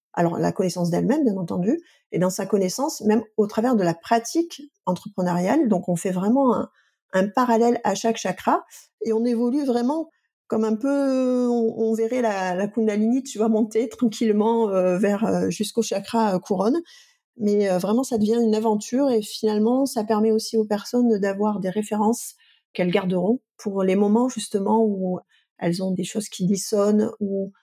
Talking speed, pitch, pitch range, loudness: 175 wpm, 220 Hz, 200-235 Hz, -22 LUFS